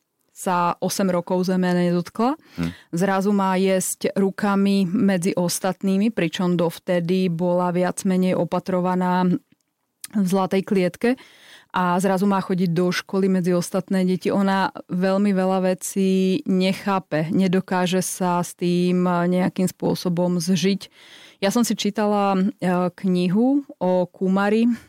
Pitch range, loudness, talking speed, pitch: 180-195 Hz, -21 LUFS, 115 wpm, 185 Hz